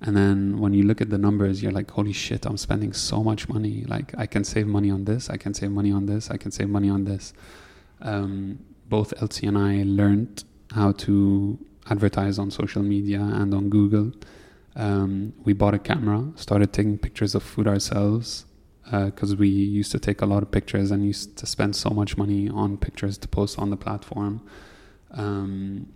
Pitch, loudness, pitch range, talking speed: 100 Hz, -24 LUFS, 100-105 Hz, 200 wpm